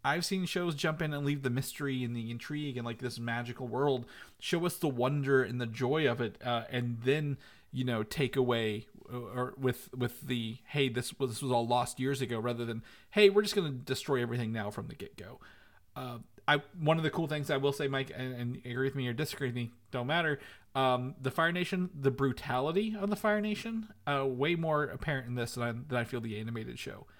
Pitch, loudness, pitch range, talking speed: 130 Hz, -33 LUFS, 120-150 Hz, 230 wpm